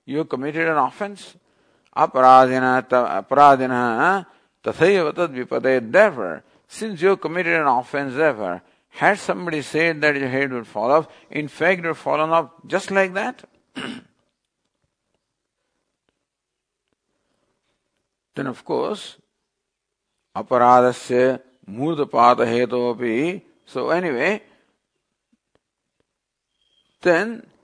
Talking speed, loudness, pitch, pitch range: 80 wpm, -19 LUFS, 145 Hz, 125-165 Hz